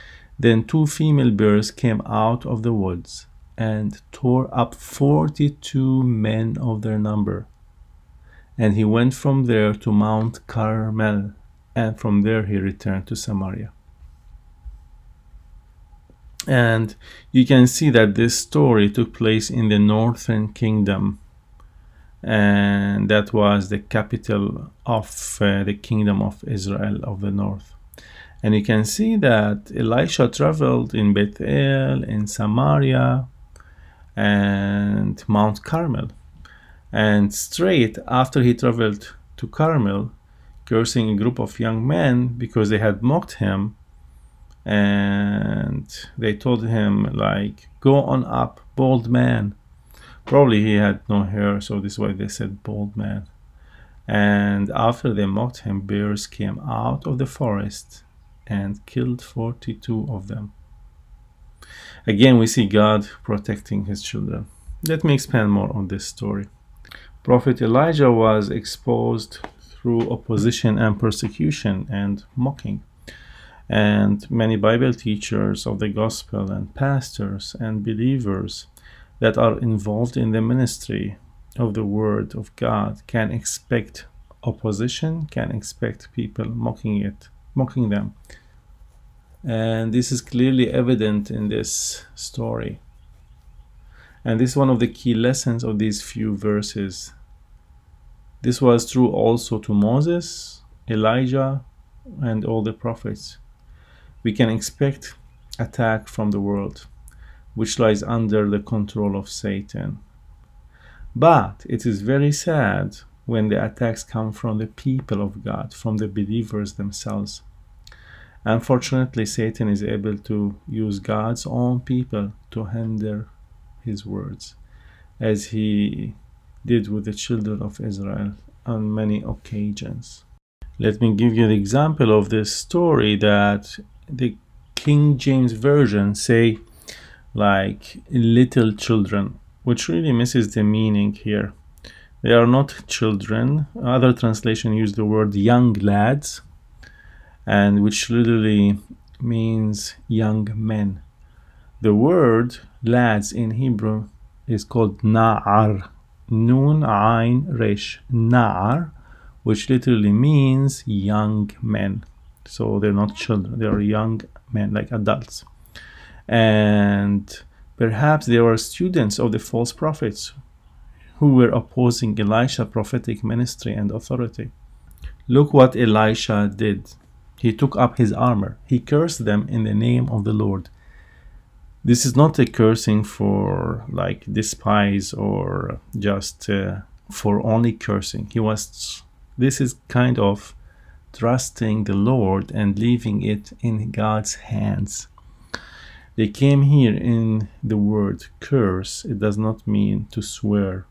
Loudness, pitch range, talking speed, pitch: -20 LUFS, 100-120 Hz, 125 wpm, 110 Hz